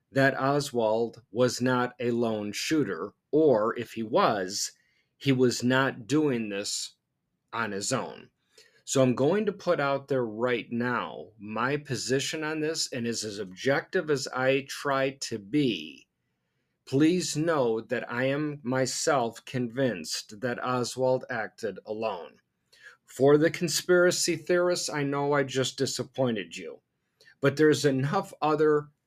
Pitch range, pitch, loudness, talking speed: 120-150 Hz, 130 Hz, -27 LUFS, 135 wpm